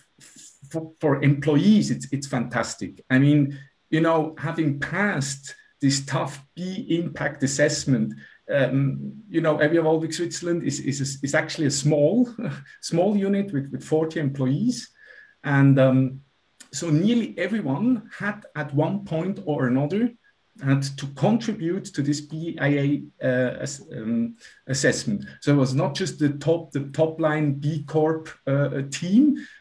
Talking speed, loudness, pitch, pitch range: 135 wpm, -24 LUFS, 155 Hz, 140-180 Hz